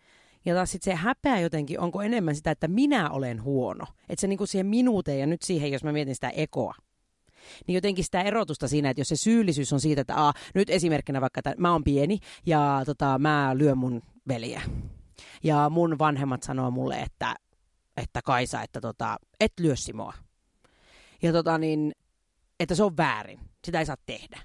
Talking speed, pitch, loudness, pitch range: 185 wpm, 155 Hz, -27 LUFS, 140-180 Hz